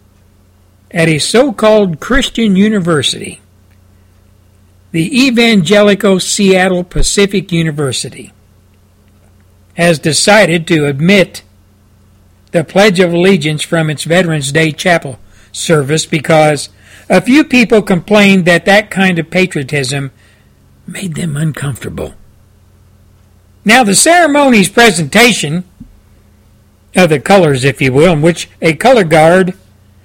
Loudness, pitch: -9 LUFS, 160 Hz